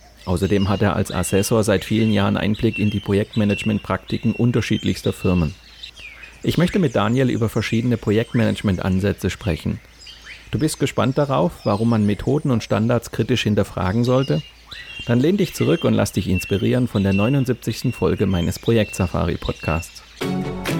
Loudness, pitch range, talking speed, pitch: -20 LUFS, 100-120 Hz, 140 wpm, 105 Hz